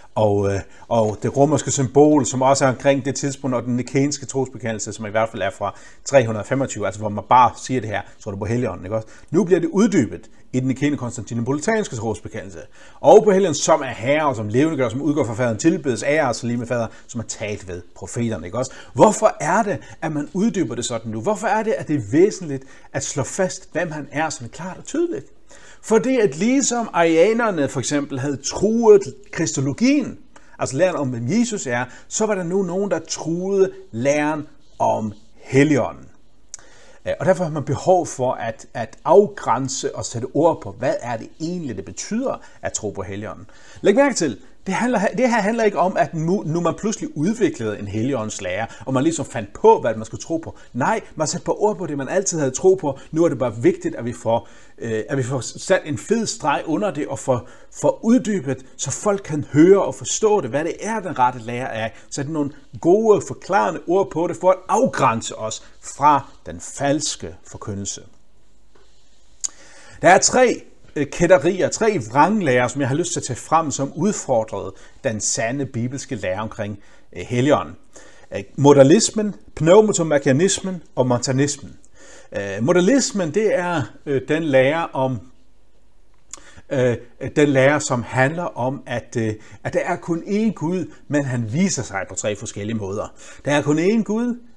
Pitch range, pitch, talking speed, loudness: 120-180 Hz, 140 Hz, 185 wpm, -20 LUFS